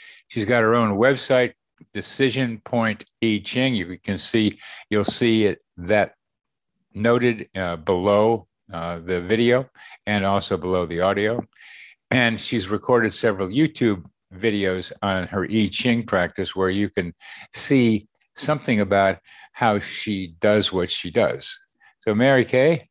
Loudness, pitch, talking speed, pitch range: -22 LUFS, 105 Hz, 140 wpm, 95-120 Hz